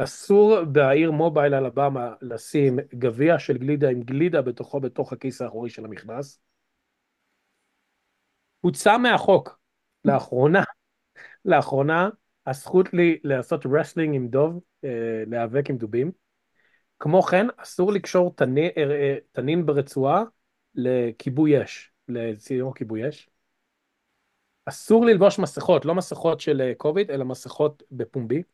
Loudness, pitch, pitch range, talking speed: -22 LUFS, 145 Hz, 130-165 Hz, 105 wpm